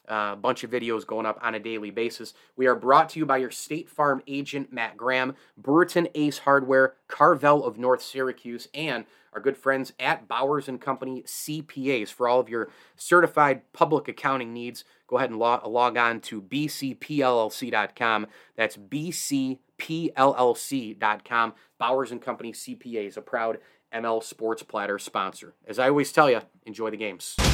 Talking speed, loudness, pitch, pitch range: 160 wpm, -25 LUFS, 130 Hz, 115-140 Hz